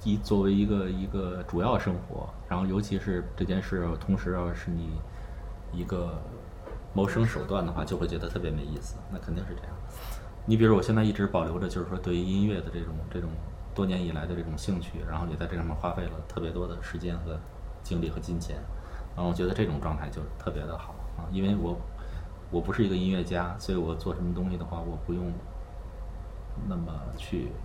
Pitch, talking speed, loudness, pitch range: 90 Hz, 310 characters per minute, -31 LUFS, 85-95 Hz